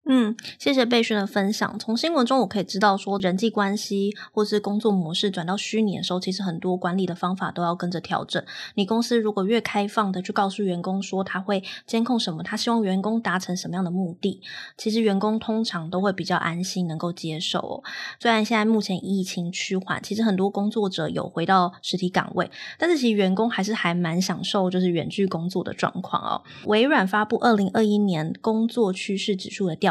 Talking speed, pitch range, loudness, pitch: 330 characters per minute, 180-215 Hz, -24 LUFS, 195 Hz